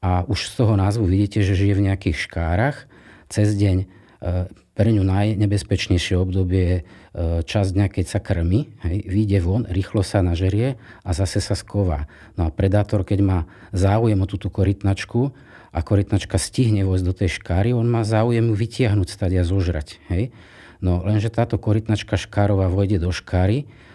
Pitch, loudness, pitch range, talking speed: 100 Hz, -21 LUFS, 95-110 Hz, 165 wpm